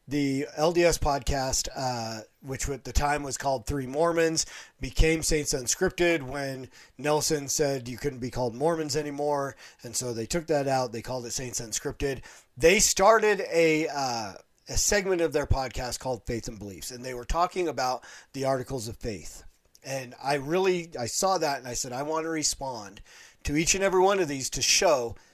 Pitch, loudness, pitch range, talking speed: 140 Hz, -27 LUFS, 125-160 Hz, 185 wpm